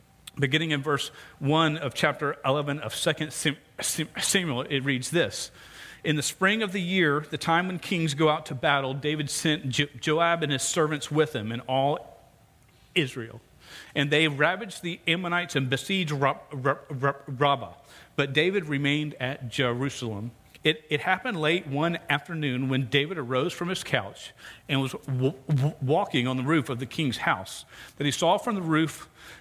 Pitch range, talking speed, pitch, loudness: 135-160 Hz, 165 wpm, 145 Hz, -26 LUFS